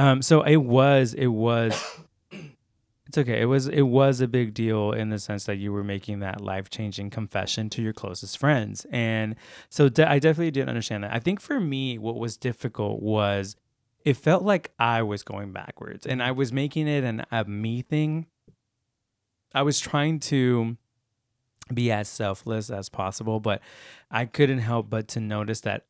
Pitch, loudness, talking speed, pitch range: 115 Hz, -25 LUFS, 185 wpm, 105-135 Hz